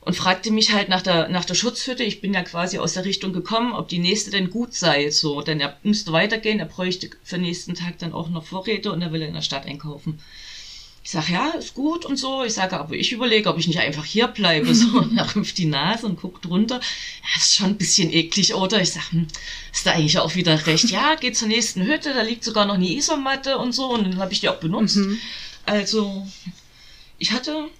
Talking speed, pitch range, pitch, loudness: 235 wpm, 170-230 Hz, 195 Hz, -21 LUFS